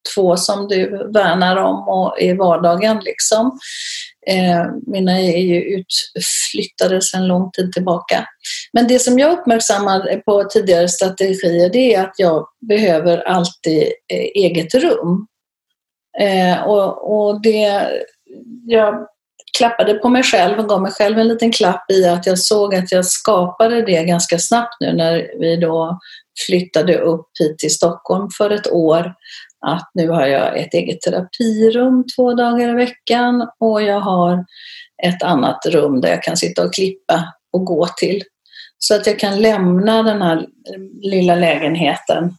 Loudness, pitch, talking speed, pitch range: -15 LUFS, 190 Hz, 155 wpm, 175-225 Hz